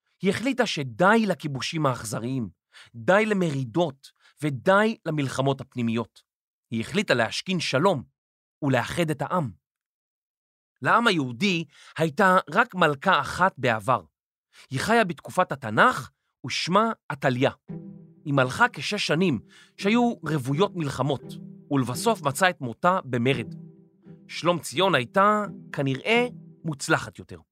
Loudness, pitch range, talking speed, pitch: -24 LUFS, 135-190 Hz, 105 wpm, 165 Hz